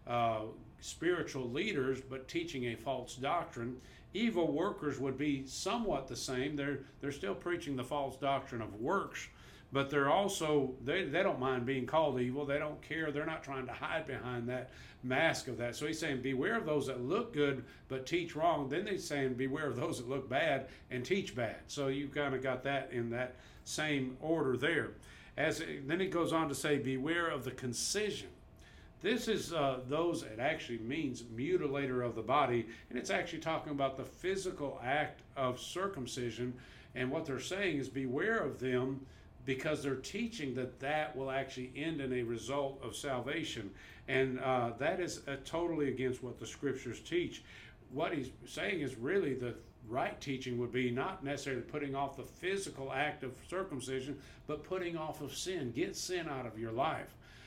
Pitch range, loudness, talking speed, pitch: 125-155 Hz, -37 LUFS, 185 wpm, 135 Hz